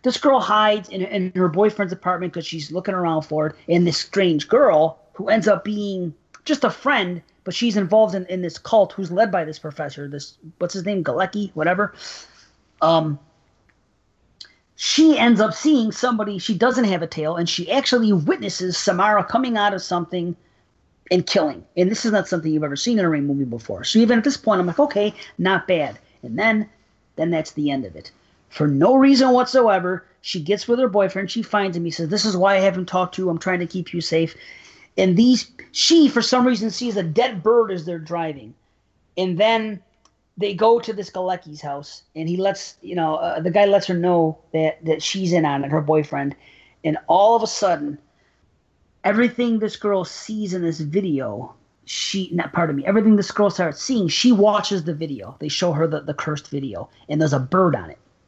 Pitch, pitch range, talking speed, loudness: 185 Hz, 160-210 Hz, 210 wpm, -20 LUFS